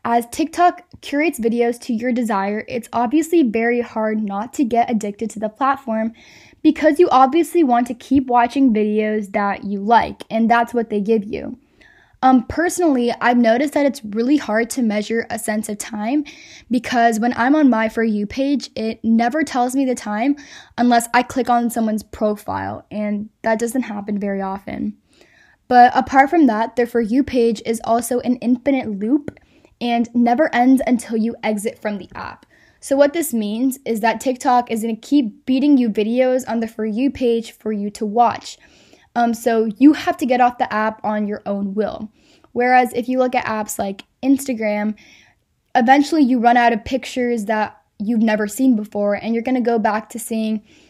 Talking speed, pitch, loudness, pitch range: 185 wpm, 235 Hz, -18 LUFS, 220-260 Hz